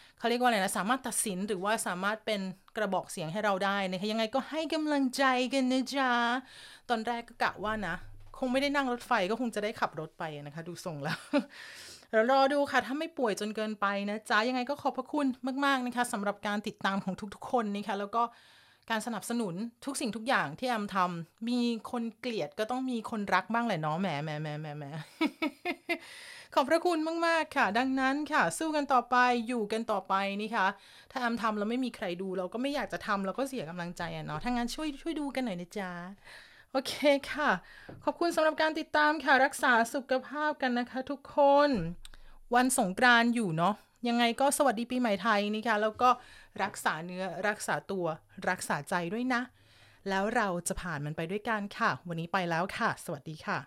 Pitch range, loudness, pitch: 195-265 Hz, -31 LUFS, 235 Hz